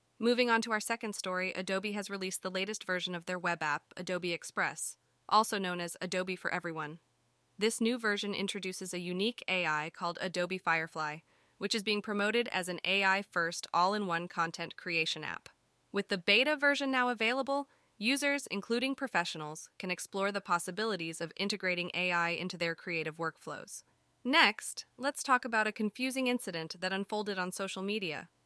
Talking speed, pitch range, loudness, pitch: 170 wpm, 175-215 Hz, -33 LUFS, 190 Hz